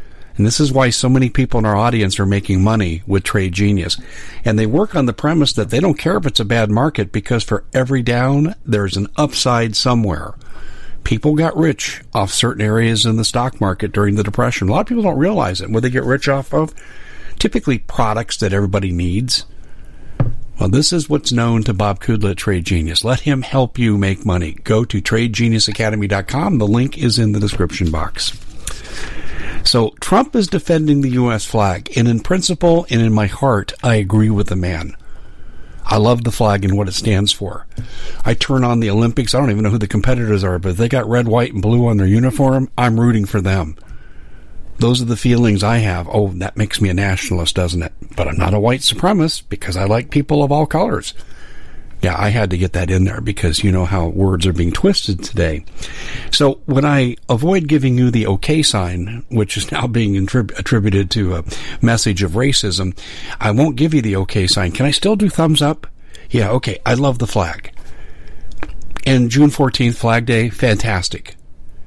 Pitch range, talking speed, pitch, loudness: 100-130 Hz, 200 wpm, 110 Hz, -16 LUFS